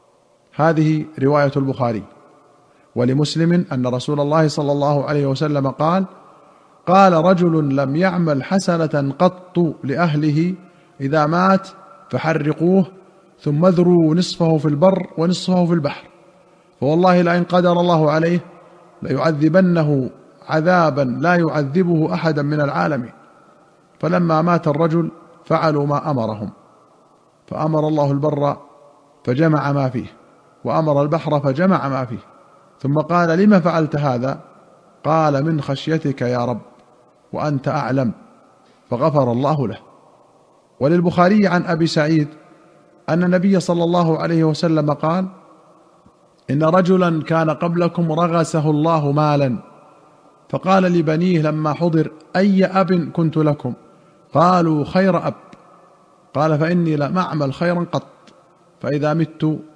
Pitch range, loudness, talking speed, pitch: 145-175 Hz, -17 LUFS, 110 wpm, 160 Hz